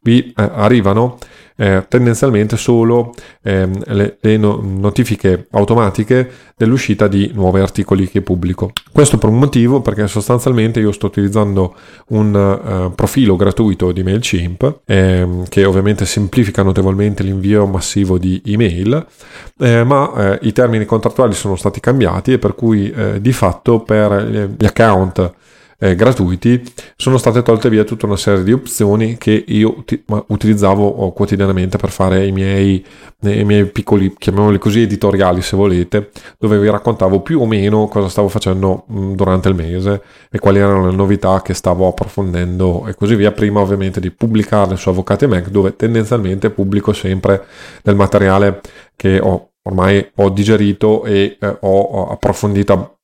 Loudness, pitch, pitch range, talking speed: -13 LUFS, 100 Hz, 95-110 Hz, 150 wpm